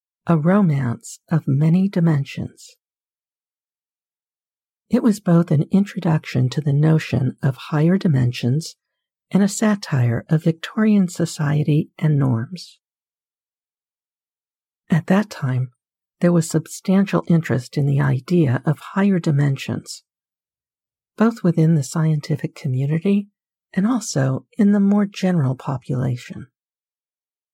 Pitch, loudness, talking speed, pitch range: 155 Hz, -19 LUFS, 105 wpm, 125-180 Hz